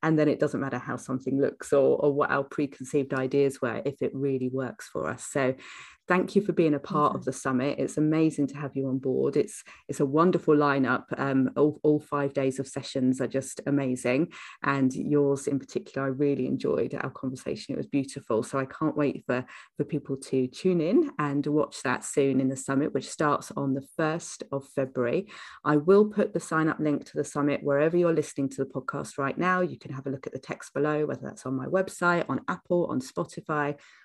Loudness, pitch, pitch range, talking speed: -28 LUFS, 140 Hz, 135-150 Hz, 220 wpm